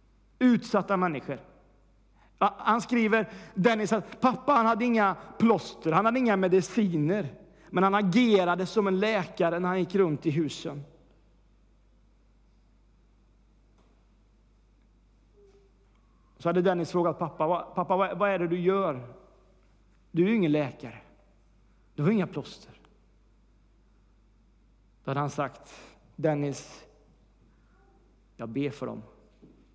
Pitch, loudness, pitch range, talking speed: 175 Hz, -27 LUFS, 140-200 Hz, 115 wpm